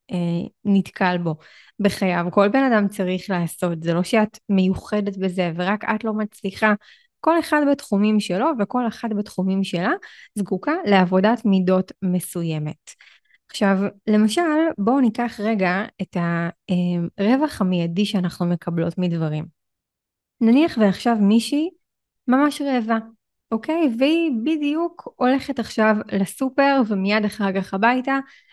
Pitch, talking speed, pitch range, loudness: 205 Hz, 115 wpm, 185-245 Hz, -21 LUFS